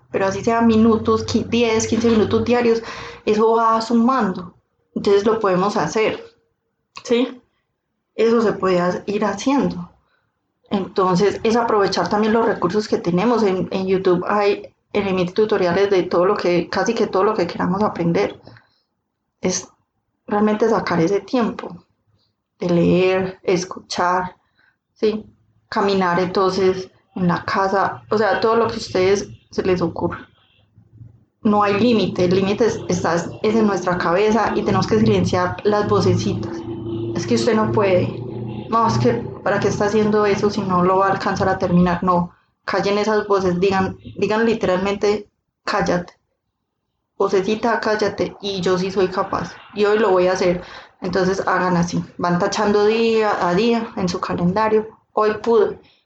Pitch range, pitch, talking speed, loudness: 180-215 Hz, 200 Hz, 150 wpm, -19 LUFS